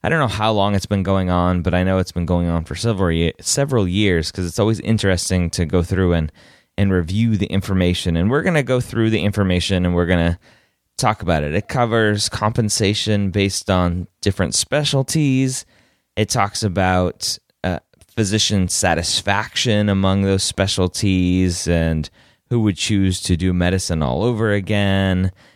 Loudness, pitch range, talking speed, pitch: -18 LUFS, 90-110 Hz, 170 wpm, 95 Hz